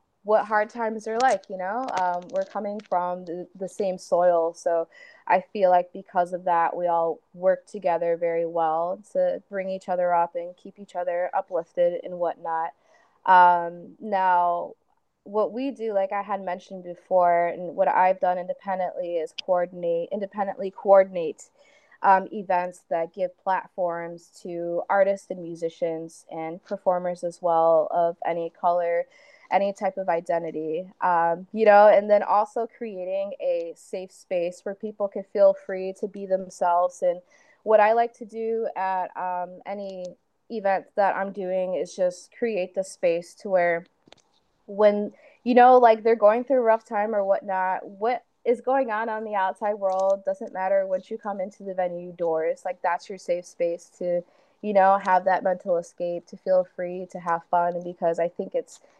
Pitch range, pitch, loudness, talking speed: 175-210 Hz, 190 Hz, -24 LUFS, 170 wpm